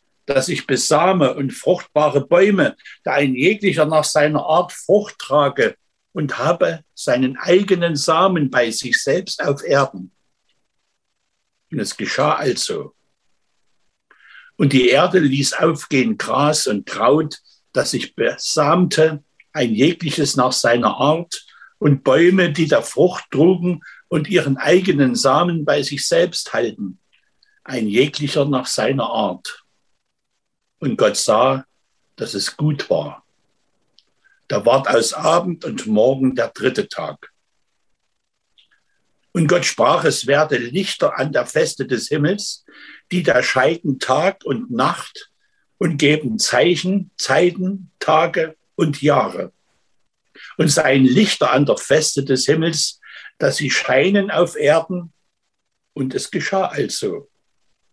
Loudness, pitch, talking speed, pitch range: -17 LUFS, 160 Hz, 125 wpm, 145-185 Hz